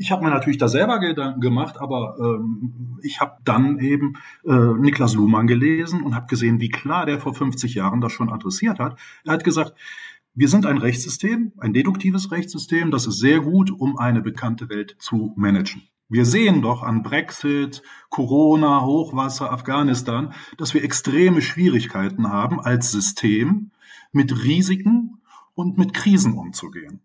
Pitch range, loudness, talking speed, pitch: 120-165 Hz, -20 LUFS, 160 wpm, 140 Hz